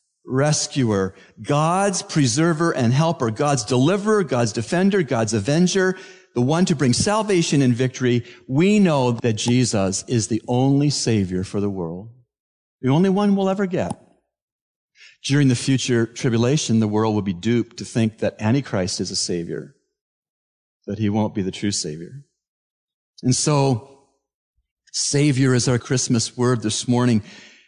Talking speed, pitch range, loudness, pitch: 145 wpm, 110-145 Hz, -20 LUFS, 125 Hz